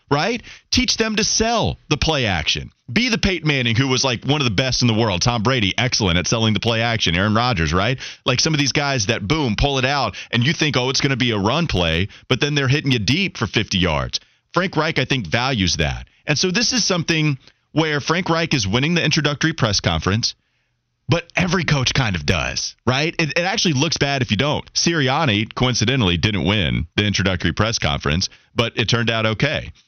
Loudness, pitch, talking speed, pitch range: -18 LUFS, 130 Hz, 225 wpm, 105-155 Hz